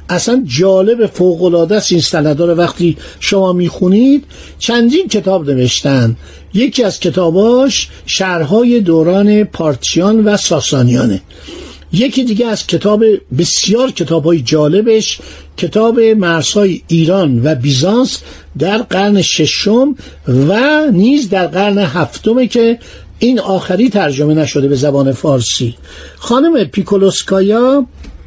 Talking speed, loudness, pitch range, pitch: 105 wpm, -11 LUFS, 155-220 Hz, 190 Hz